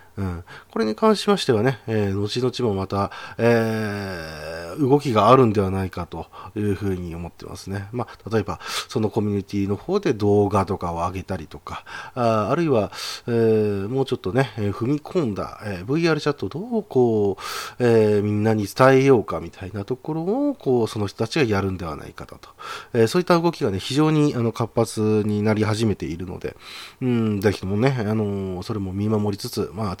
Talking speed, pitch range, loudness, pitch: 375 characters per minute, 100-125 Hz, -22 LUFS, 110 Hz